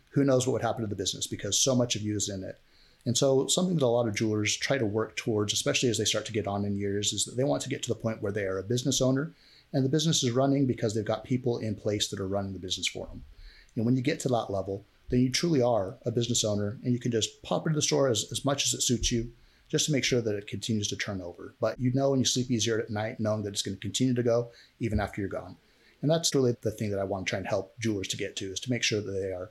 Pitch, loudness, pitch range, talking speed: 115 Hz, -28 LUFS, 105-130 Hz, 310 wpm